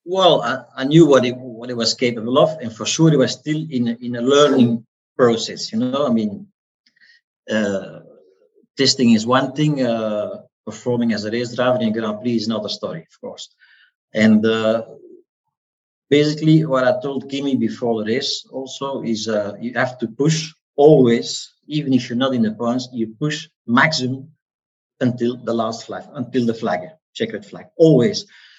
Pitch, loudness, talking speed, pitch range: 125 Hz, -18 LUFS, 175 wpm, 115-150 Hz